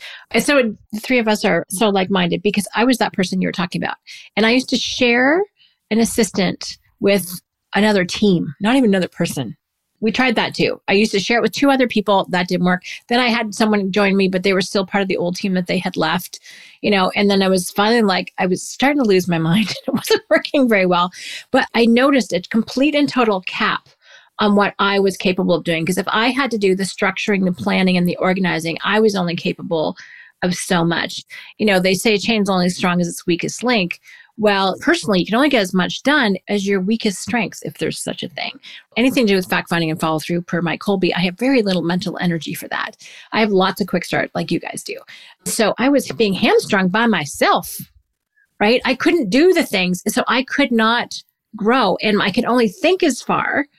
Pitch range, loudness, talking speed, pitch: 185-240 Hz, -17 LUFS, 230 wpm, 205 Hz